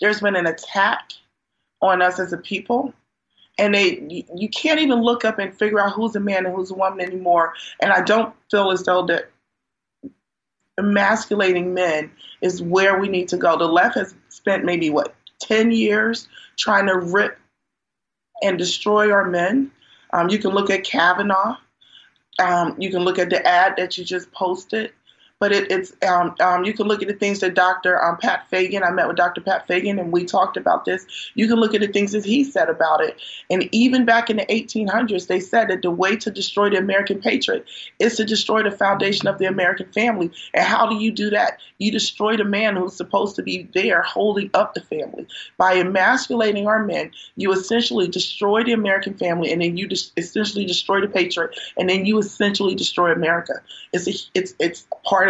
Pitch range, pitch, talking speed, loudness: 180-220 Hz, 200 Hz, 200 wpm, -19 LUFS